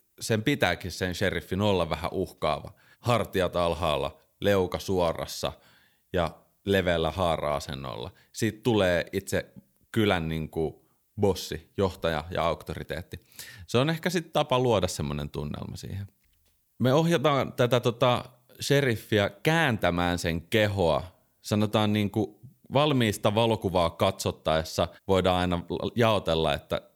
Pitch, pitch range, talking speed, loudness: 100 Hz, 85-120 Hz, 115 wpm, -27 LUFS